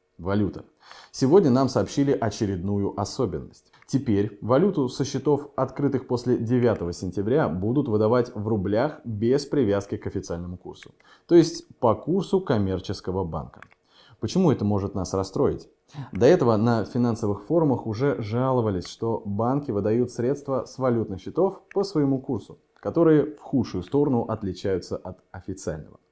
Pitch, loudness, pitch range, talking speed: 115 Hz, -24 LUFS, 100-140 Hz, 135 wpm